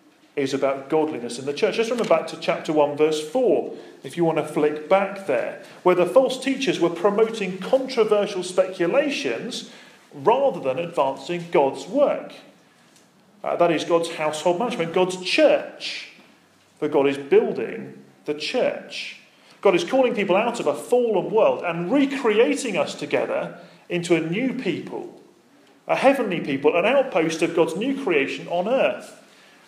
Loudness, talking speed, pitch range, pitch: -22 LUFS, 155 wpm, 165-260 Hz, 185 Hz